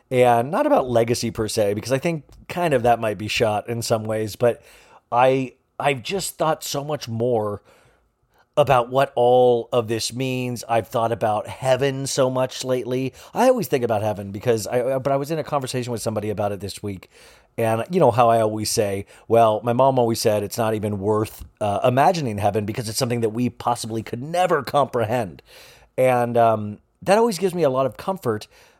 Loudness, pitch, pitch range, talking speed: -21 LUFS, 120 Hz, 110-135 Hz, 200 wpm